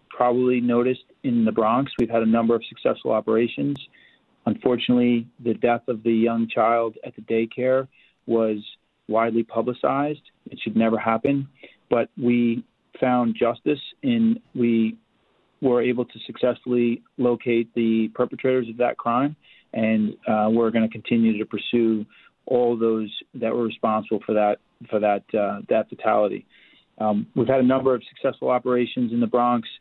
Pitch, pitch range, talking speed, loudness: 120 Hz, 115-125 Hz, 155 wpm, -23 LUFS